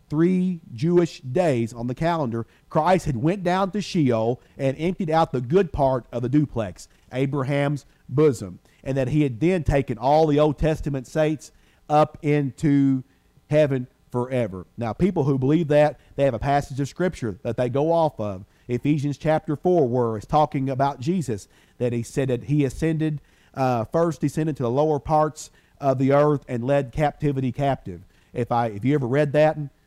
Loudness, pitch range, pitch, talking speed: -23 LUFS, 125-155 Hz, 140 Hz, 180 wpm